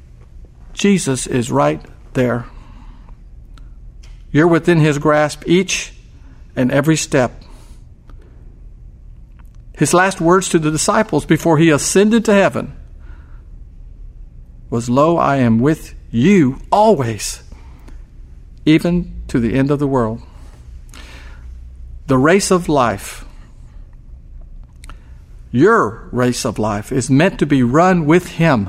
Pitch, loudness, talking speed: 125 Hz, -15 LUFS, 110 wpm